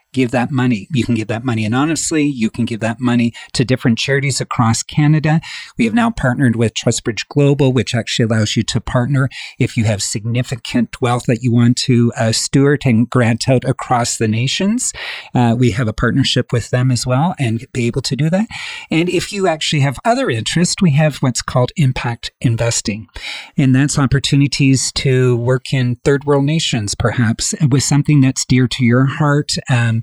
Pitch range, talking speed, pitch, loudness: 120-145 Hz, 190 wpm, 130 Hz, -15 LUFS